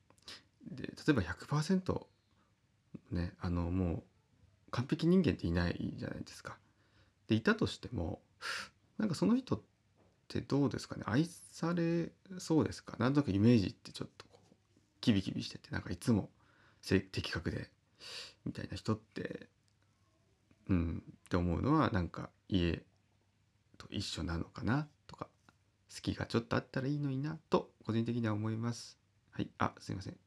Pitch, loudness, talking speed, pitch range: 105 Hz, -36 LUFS, 295 characters per minute, 100-130 Hz